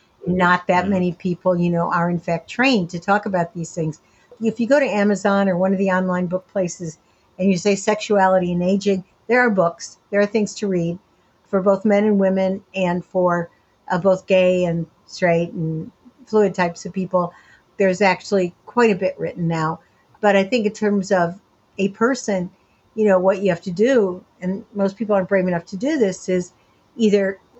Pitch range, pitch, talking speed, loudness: 180-205 Hz, 190 Hz, 200 wpm, -20 LUFS